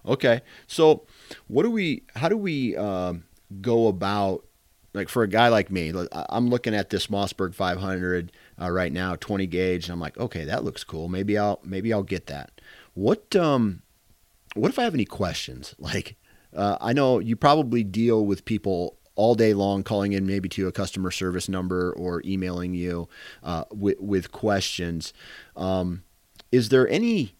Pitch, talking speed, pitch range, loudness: 95 Hz, 175 wpm, 90-115 Hz, -25 LUFS